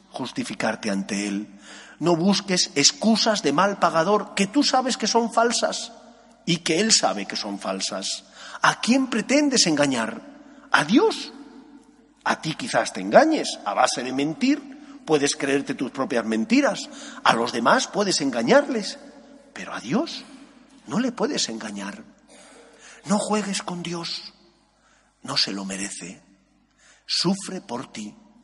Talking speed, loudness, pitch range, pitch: 135 wpm, -22 LUFS, 160-265 Hz, 220 Hz